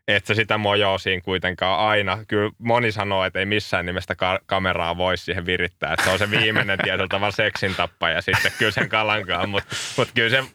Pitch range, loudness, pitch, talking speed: 90-110 Hz, -21 LUFS, 100 Hz, 195 wpm